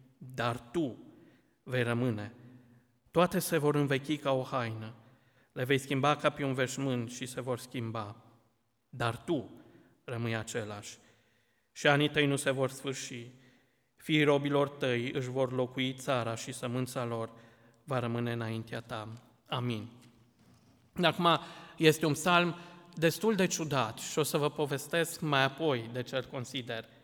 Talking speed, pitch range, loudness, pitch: 145 wpm, 120-145 Hz, -32 LUFS, 130 Hz